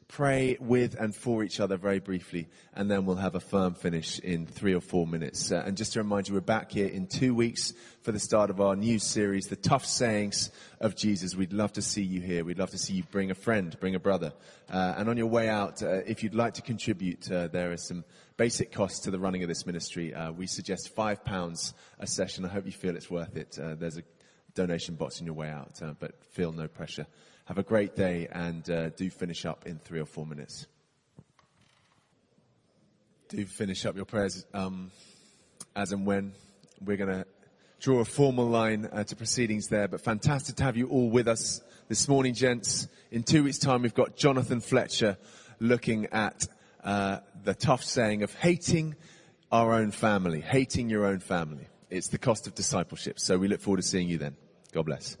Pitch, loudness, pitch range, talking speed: 100 Hz, -30 LUFS, 90-115 Hz, 210 wpm